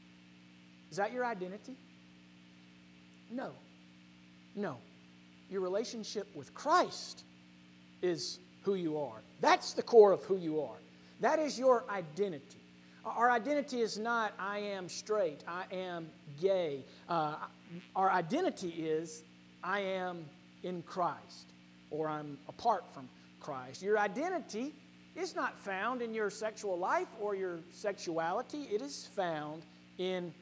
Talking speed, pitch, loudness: 130 wpm, 175 Hz, -35 LUFS